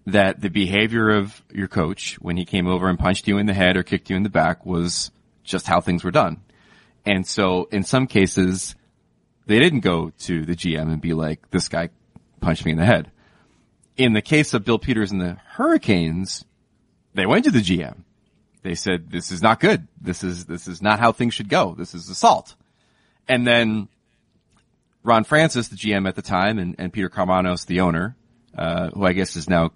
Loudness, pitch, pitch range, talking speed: -20 LUFS, 95 Hz, 90-110 Hz, 205 wpm